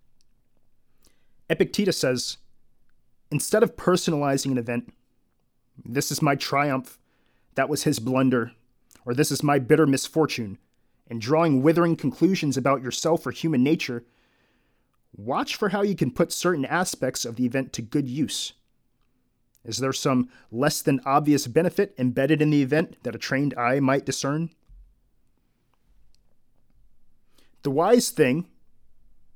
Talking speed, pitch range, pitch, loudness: 130 wpm, 125-160 Hz, 140 Hz, -24 LUFS